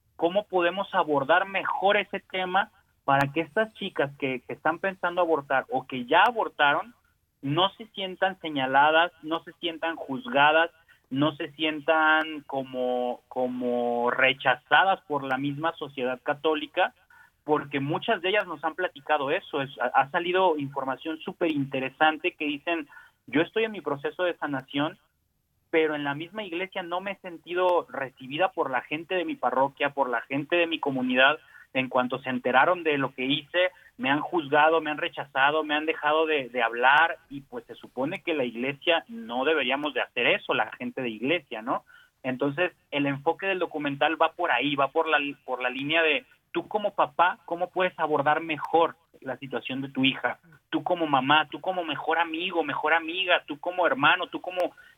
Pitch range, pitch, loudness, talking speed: 135-175 Hz, 155 Hz, -26 LUFS, 175 wpm